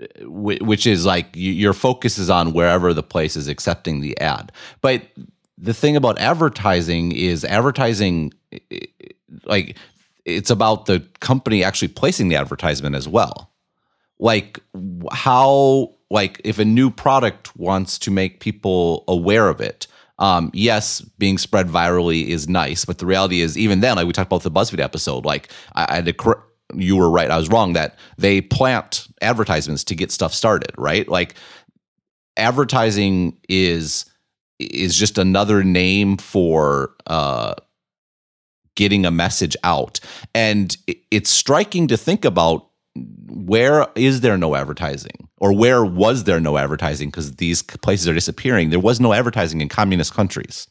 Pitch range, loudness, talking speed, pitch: 85-110 Hz, -18 LUFS, 150 wpm, 95 Hz